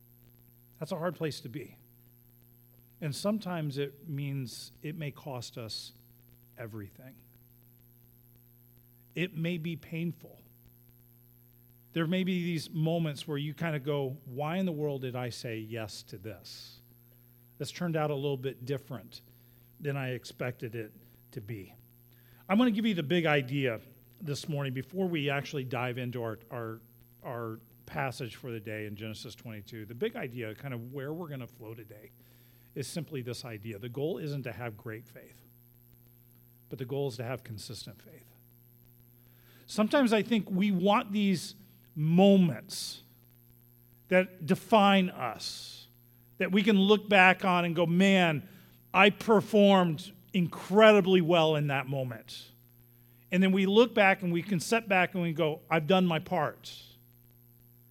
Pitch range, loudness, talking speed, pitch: 120-165 Hz, -29 LUFS, 155 wpm, 125 Hz